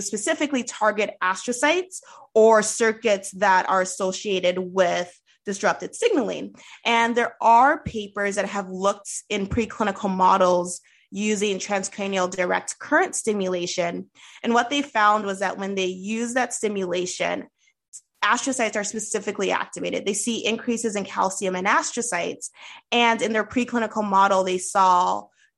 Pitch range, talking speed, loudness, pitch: 190-230 Hz, 130 wpm, -22 LUFS, 210 Hz